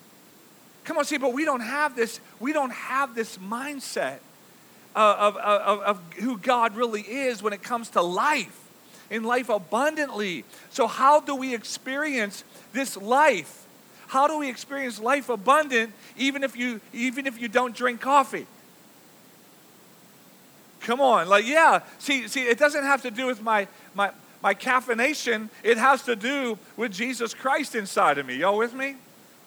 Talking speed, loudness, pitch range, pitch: 165 wpm, -24 LUFS, 220-275 Hz, 245 Hz